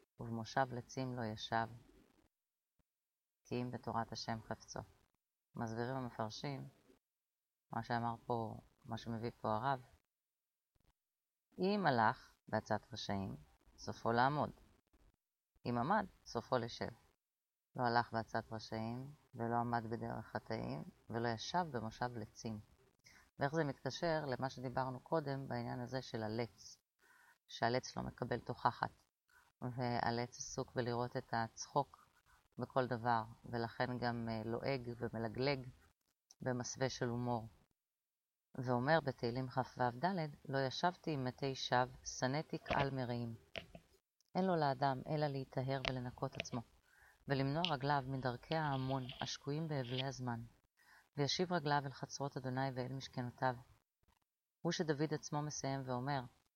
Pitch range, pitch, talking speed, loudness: 115-135 Hz, 125 Hz, 110 wpm, -41 LUFS